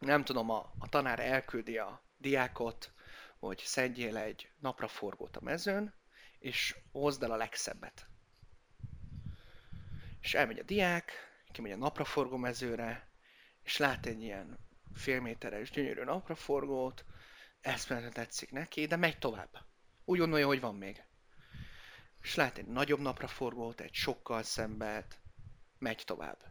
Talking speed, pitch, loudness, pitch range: 130 wpm, 125 Hz, -36 LUFS, 115-140 Hz